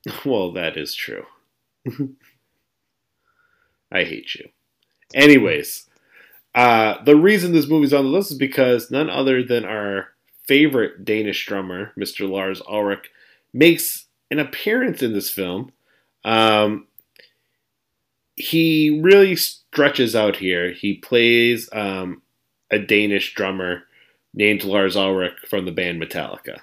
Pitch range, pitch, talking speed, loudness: 100-145 Hz, 120 Hz, 120 wpm, -18 LUFS